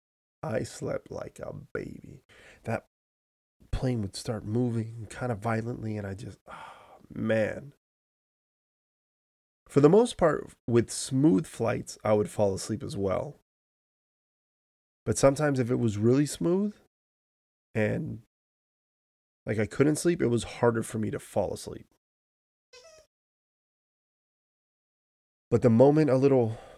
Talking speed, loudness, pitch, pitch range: 125 wpm, -27 LUFS, 115 Hz, 105-135 Hz